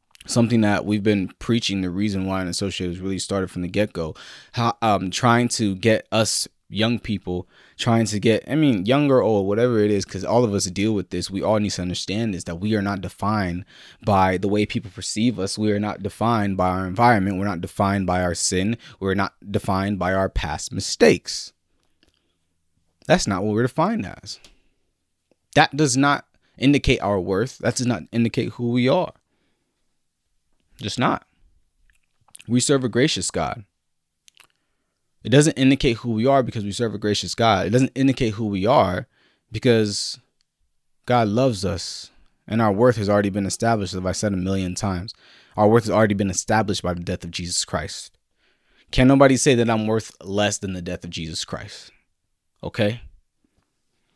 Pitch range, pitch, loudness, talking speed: 95-115 Hz, 105 Hz, -21 LUFS, 185 wpm